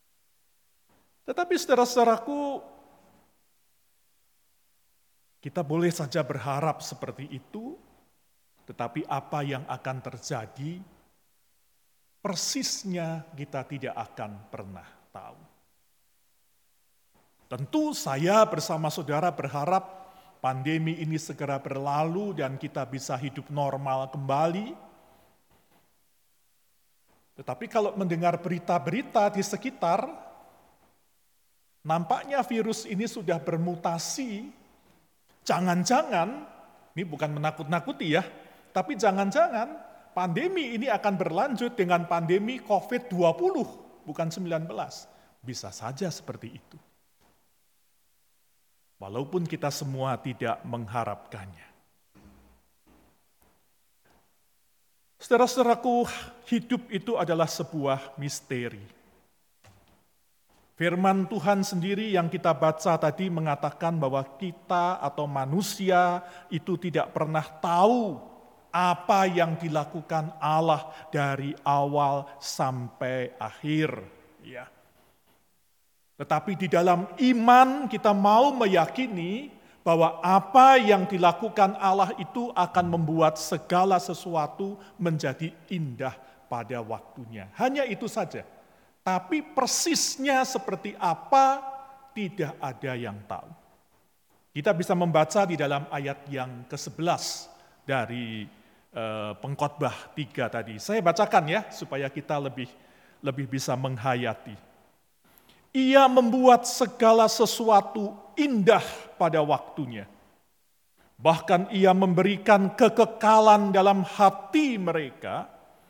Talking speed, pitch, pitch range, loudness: 85 wpm, 170 Hz, 140-205 Hz, -26 LUFS